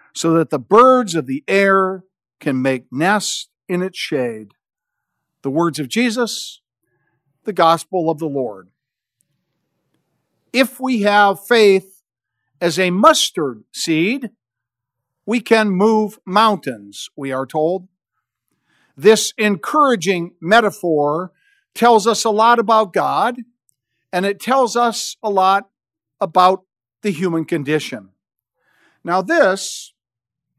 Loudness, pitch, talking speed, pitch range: -16 LUFS, 185 Hz, 115 wpm, 145-220 Hz